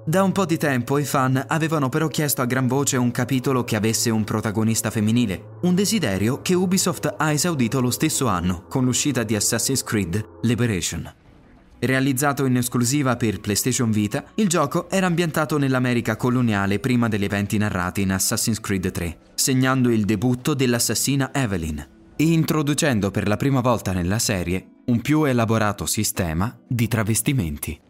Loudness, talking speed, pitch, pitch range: -21 LUFS, 160 wpm, 120 Hz, 105-140 Hz